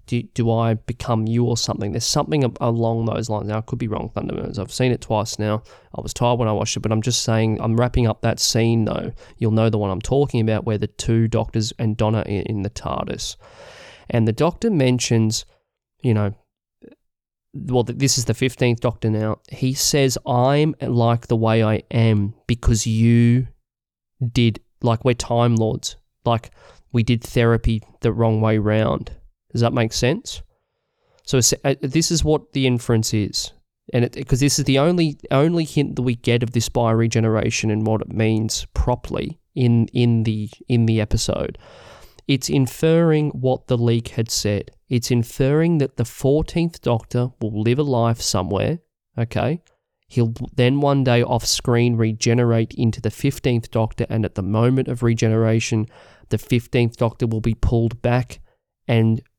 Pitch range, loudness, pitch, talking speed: 110-125 Hz, -20 LUFS, 115 Hz, 175 wpm